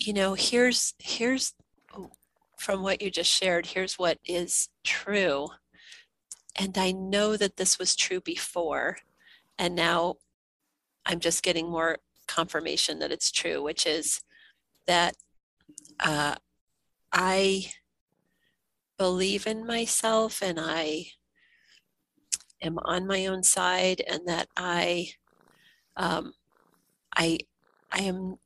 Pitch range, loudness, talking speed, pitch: 170-205 Hz, -27 LUFS, 110 wpm, 185 Hz